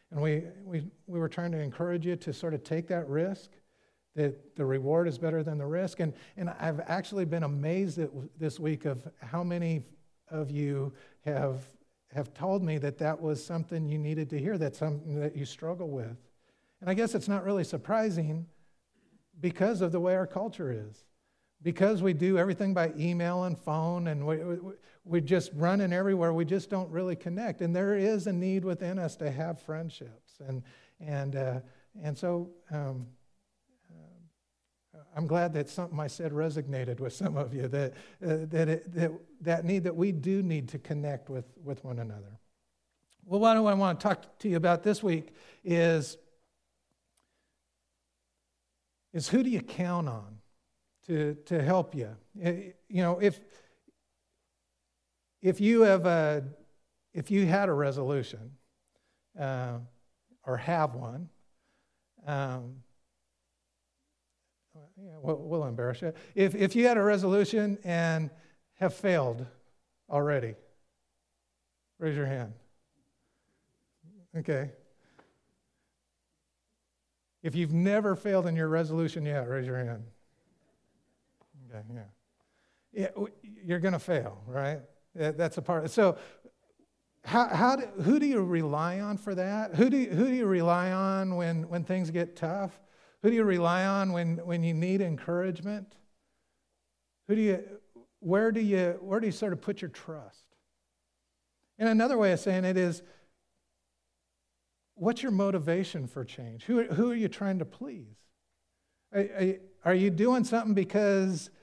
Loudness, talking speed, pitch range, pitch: -30 LUFS, 155 wpm, 135-185 Hz, 165 Hz